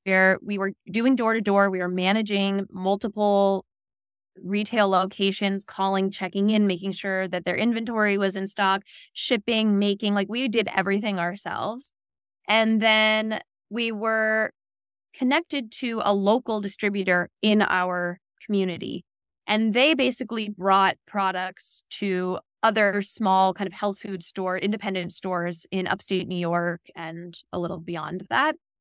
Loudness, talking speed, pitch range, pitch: -24 LUFS, 140 wpm, 185-215 Hz, 195 Hz